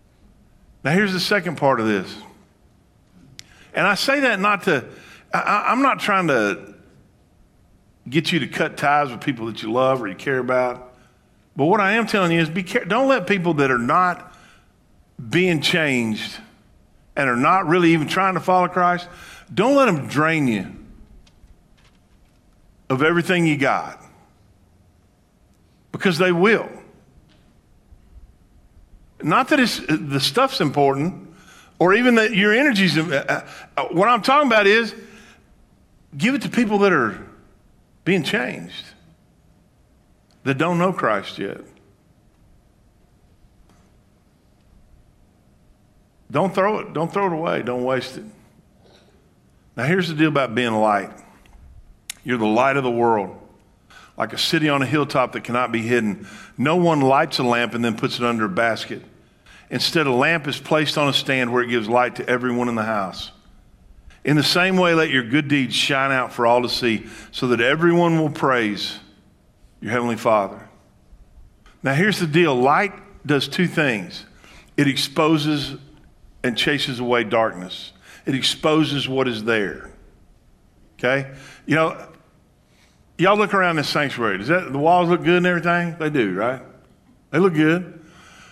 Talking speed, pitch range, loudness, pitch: 155 wpm, 120-175 Hz, -19 LUFS, 145 Hz